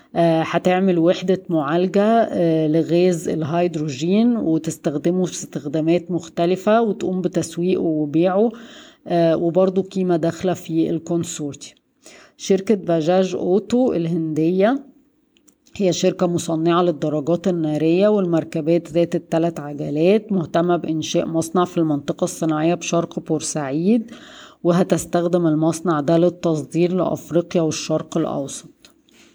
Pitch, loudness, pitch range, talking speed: 170 Hz, -20 LUFS, 165-185 Hz, 90 wpm